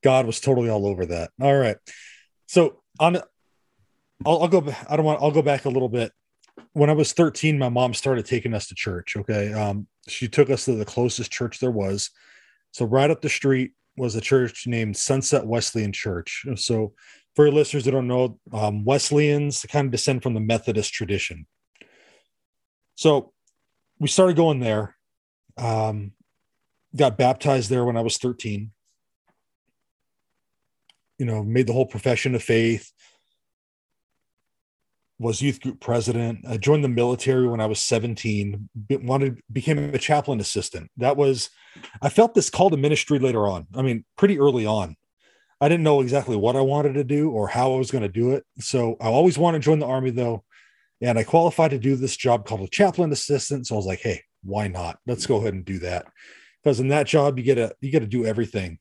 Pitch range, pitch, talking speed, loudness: 110-140 Hz, 125 Hz, 190 wpm, -22 LUFS